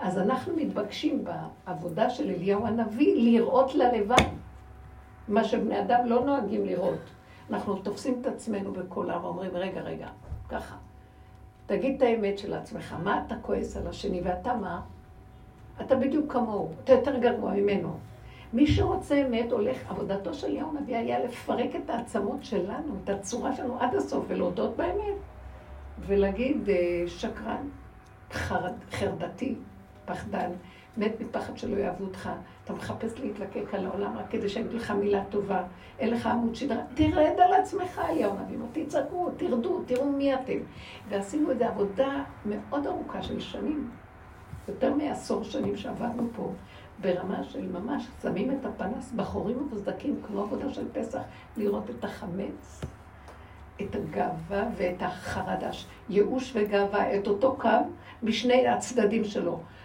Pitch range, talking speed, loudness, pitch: 195-255 Hz, 140 wpm, -29 LUFS, 230 Hz